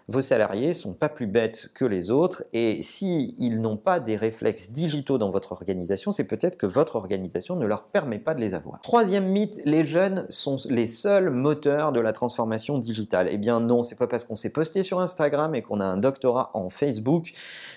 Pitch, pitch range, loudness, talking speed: 135 Hz, 115-165 Hz, -25 LUFS, 215 wpm